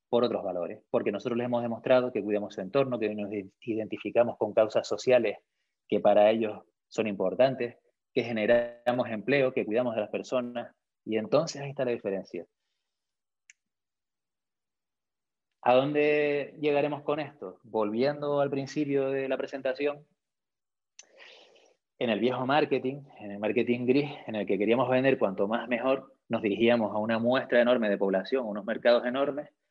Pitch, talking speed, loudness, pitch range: 125 Hz, 155 wpm, -28 LUFS, 110-140 Hz